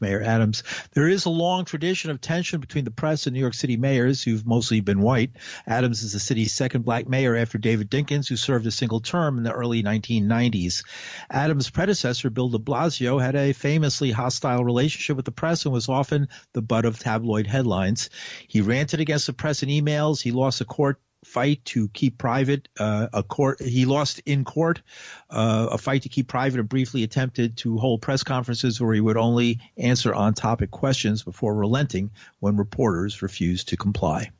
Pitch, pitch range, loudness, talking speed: 125 Hz, 115-140 Hz, -23 LUFS, 195 wpm